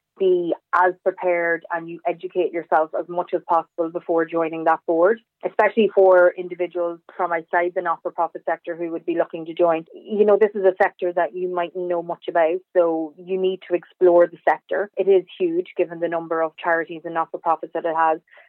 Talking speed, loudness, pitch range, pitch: 215 wpm, -21 LUFS, 165-185 Hz, 175 Hz